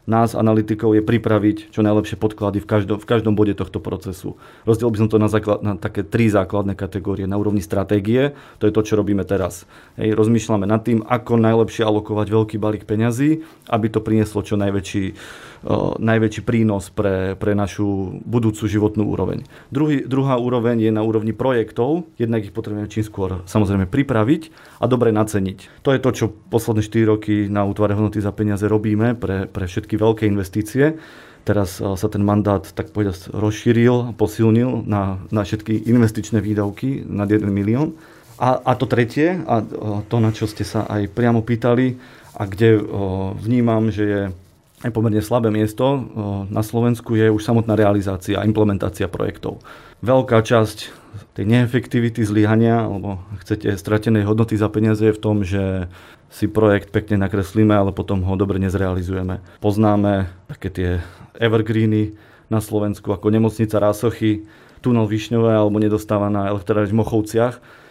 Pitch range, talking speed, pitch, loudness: 100-115 Hz, 160 wpm, 110 Hz, -19 LUFS